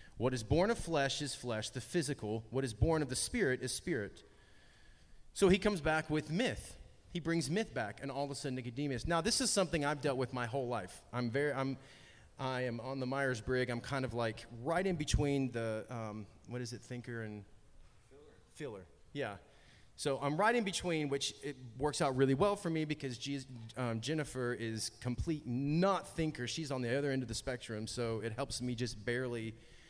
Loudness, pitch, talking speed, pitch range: -37 LUFS, 130 Hz, 210 wpm, 120-150 Hz